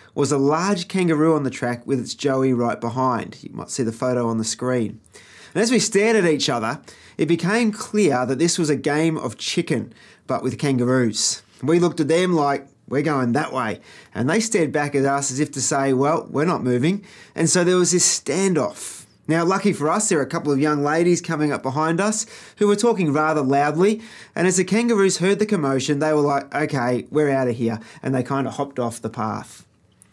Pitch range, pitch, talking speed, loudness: 130-180 Hz, 150 Hz, 225 wpm, -20 LUFS